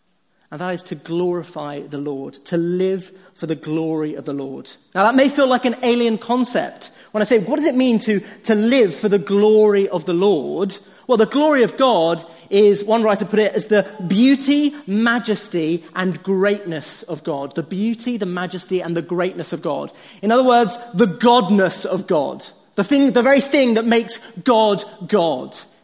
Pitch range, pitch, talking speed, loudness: 180-235 Hz, 205 Hz, 190 wpm, -18 LUFS